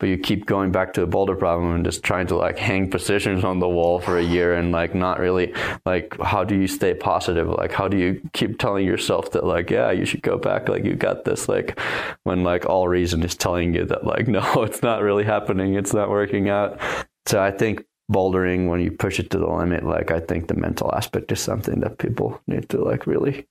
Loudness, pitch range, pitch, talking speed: -22 LUFS, 90-100 Hz, 95 Hz, 240 wpm